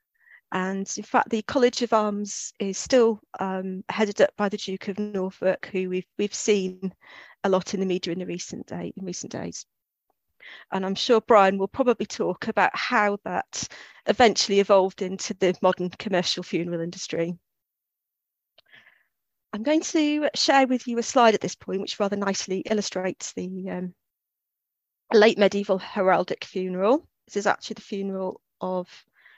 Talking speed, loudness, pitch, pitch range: 160 wpm, -25 LUFS, 195 Hz, 185-220 Hz